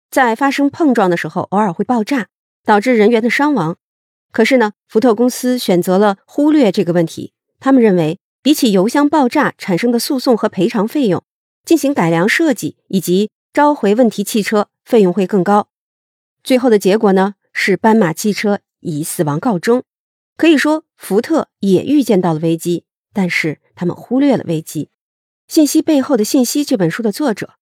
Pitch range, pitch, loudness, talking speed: 190-270 Hz, 215 Hz, -14 LUFS, 270 characters per minute